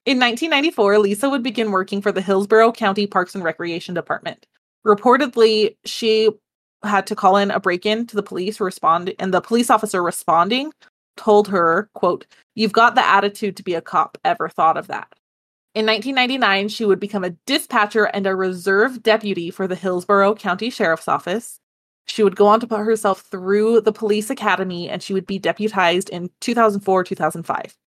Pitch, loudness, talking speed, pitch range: 205 Hz, -18 LUFS, 175 wpm, 190-220 Hz